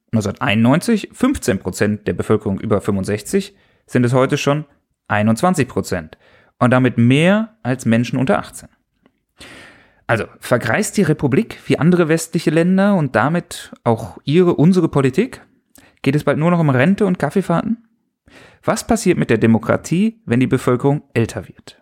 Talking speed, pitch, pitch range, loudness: 145 wpm, 140 Hz, 115-180 Hz, -17 LUFS